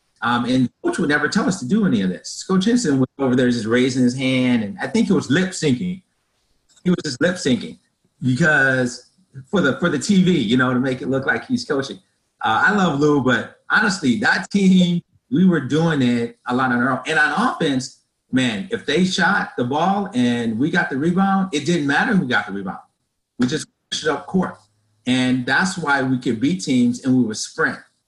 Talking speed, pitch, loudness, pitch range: 220 wpm, 150 Hz, -19 LUFS, 125-190 Hz